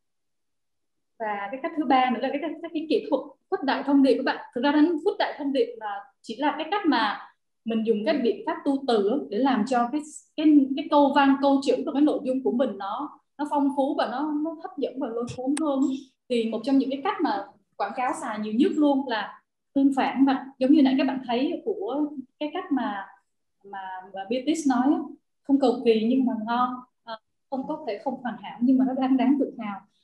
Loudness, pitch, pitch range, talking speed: -25 LUFS, 270 Hz, 240-295 Hz, 230 wpm